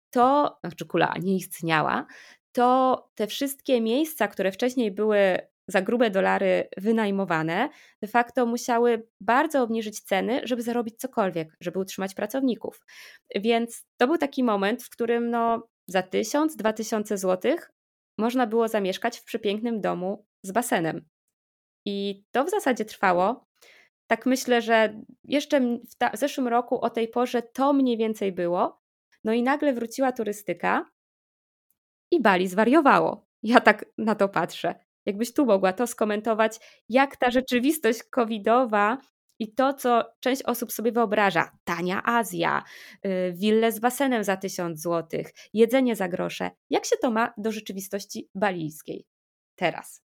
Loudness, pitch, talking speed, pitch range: -25 LUFS, 225 Hz, 140 wpm, 195-245 Hz